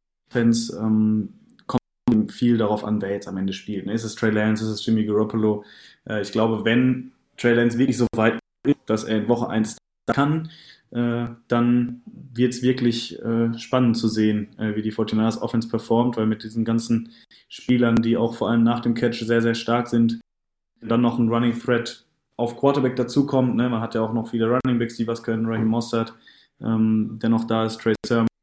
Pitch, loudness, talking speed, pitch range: 115 Hz, -22 LUFS, 200 wpm, 110-120 Hz